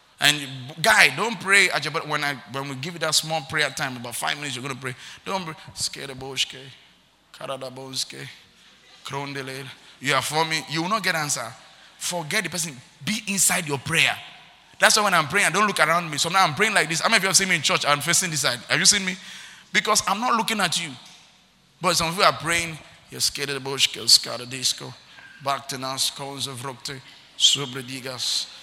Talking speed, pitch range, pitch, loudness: 210 wpm, 135-180 Hz, 155 Hz, -21 LUFS